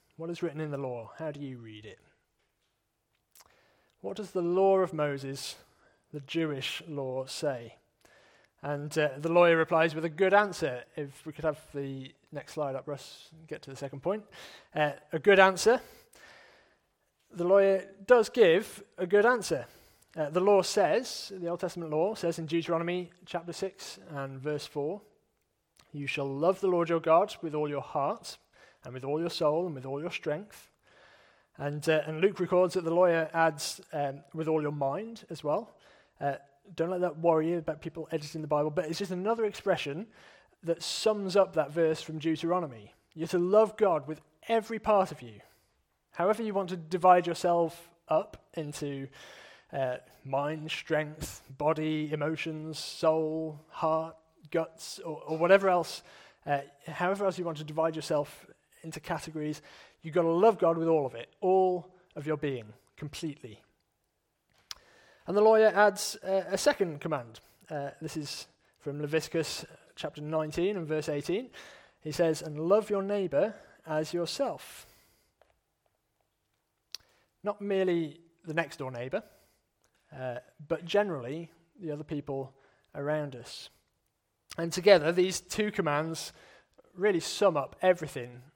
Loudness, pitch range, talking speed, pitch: -30 LUFS, 145-180 Hz, 160 wpm, 160 Hz